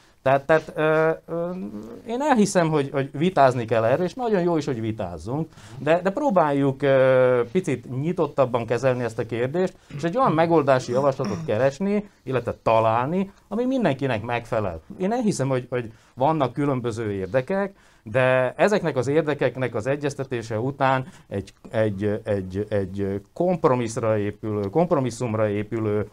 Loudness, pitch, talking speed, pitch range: -23 LUFS, 135 Hz, 135 wpm, 115-165 Hz